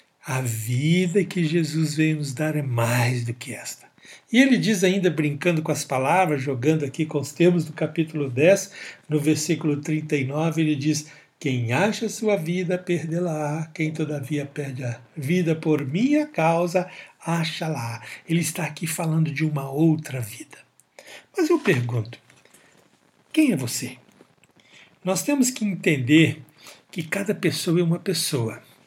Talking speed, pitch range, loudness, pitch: 150 wpm, 145-175 Hz, -23 LUFS, 155 Hz